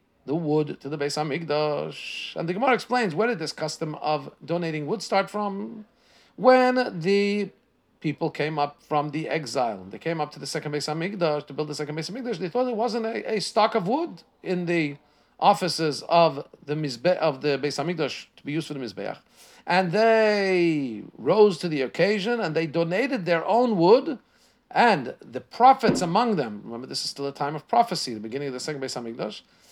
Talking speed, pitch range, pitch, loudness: 195 wpm, 150-215 Hz, 165 Hz, -25 LUFS